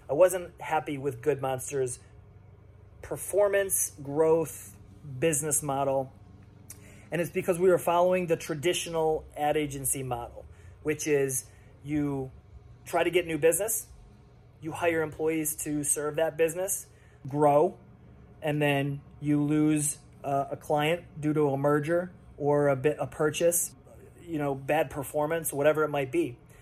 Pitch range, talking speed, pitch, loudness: 130-160 Hz, 140 wpm, 150 Hz, -28 LUFS